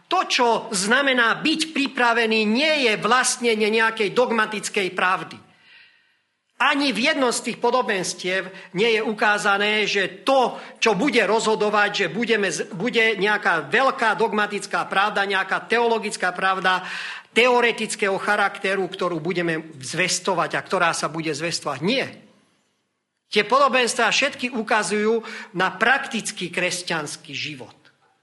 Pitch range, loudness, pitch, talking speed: 190-240 Hz, -21 LUFS, 215 Hz, 115 wpm